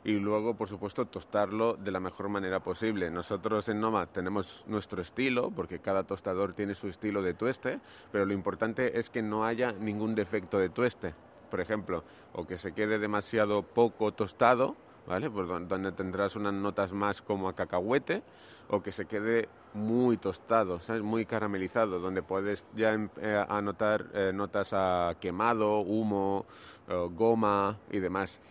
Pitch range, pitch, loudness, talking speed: 95-110 Hz, 105 Hz, -32 LUFS, 160 wpm